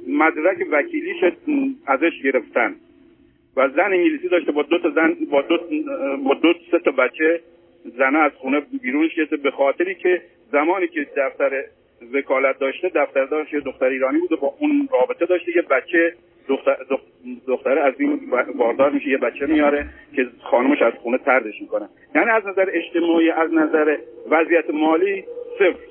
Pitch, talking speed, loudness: 170 Hz, 155 wpm, -20 LUFS